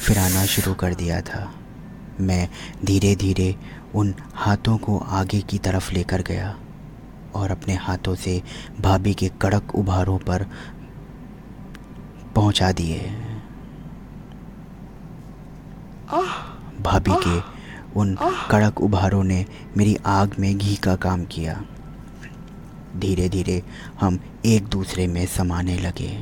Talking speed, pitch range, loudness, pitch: 110 wpm, 90-100 Hz, -22 LUFS, 95 Hz